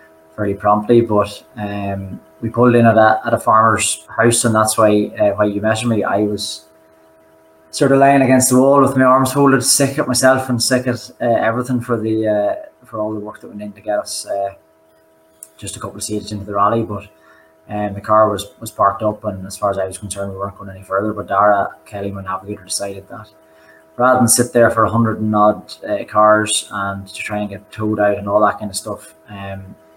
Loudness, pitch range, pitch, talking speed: -16 LUFS, 100-115 Hz, 105 Hz, 230 wpm